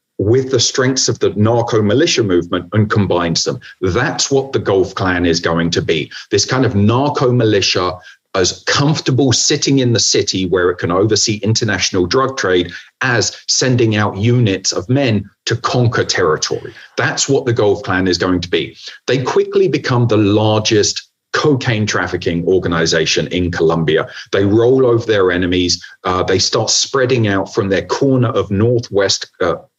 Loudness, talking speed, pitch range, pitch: -14 LUFS, 165 wpm, 95-125 Hz, 110 Hz